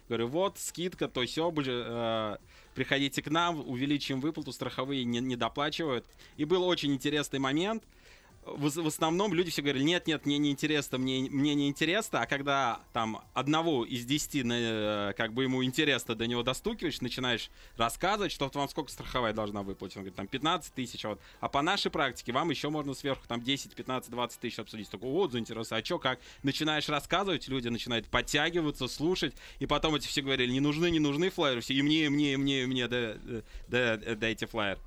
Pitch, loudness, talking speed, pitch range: 135 Hz, -31 LUFS, 205 wpm, 115-150 Hz